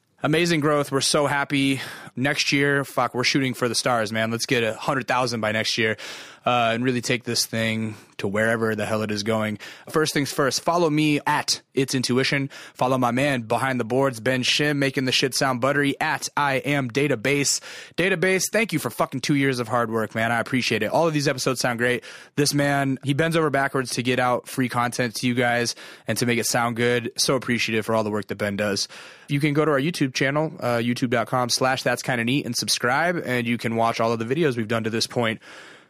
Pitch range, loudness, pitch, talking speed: 115-140 Hz, -22 LUFS, 125 Hz, 230 wpm